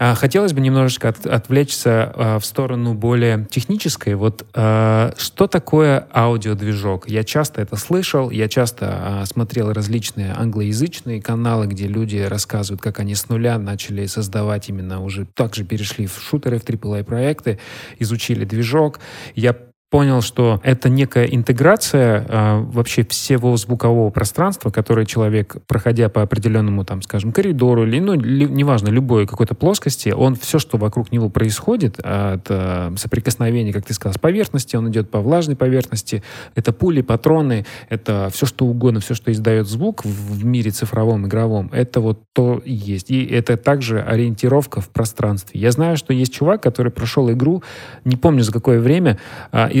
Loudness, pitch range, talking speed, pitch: -18 LUFS, 110-130 Hz, 160 wpm, 115 Hz